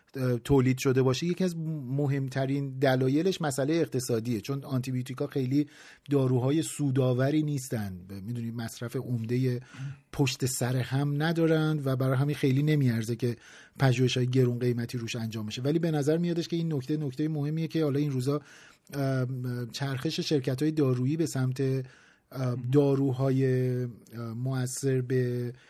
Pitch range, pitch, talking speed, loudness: 125-145 Hz, 135 Hz, 130 wpm, -29 LUFS